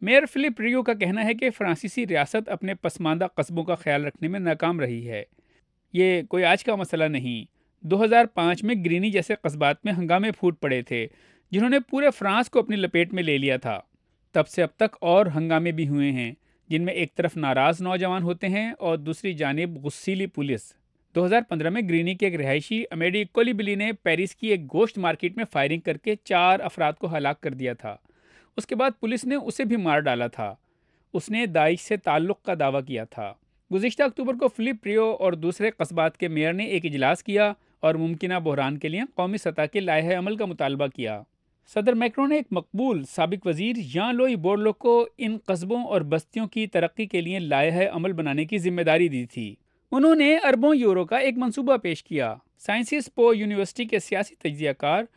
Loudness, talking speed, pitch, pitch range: -24 LUFS, 200 wpm, 185 Hz, 160-220 Hz